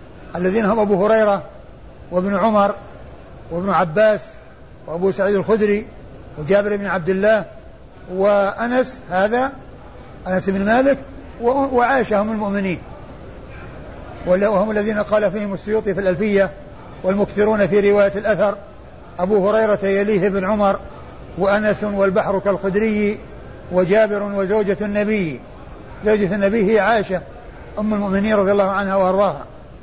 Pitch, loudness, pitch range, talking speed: 200 Hz, -18 LUFS, 190-210 Hz, 110 wpm